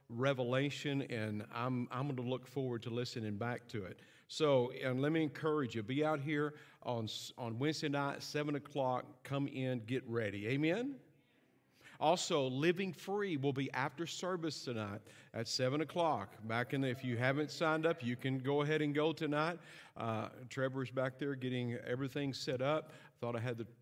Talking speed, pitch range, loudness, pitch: 180 wpm, 120-150 Hz, -38 LUFS, 135 Hz